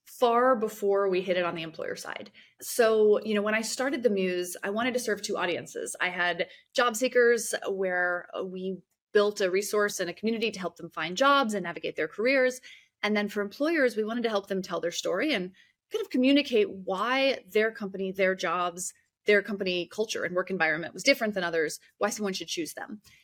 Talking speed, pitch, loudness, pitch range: 205 wpm, 205 Hz, -28 LUFS, 185-235 Hz